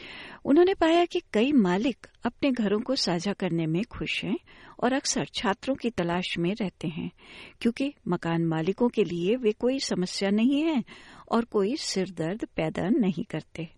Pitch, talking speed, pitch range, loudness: 215 Hz, 160 wpm, 185-270 Hz, -27 LUFS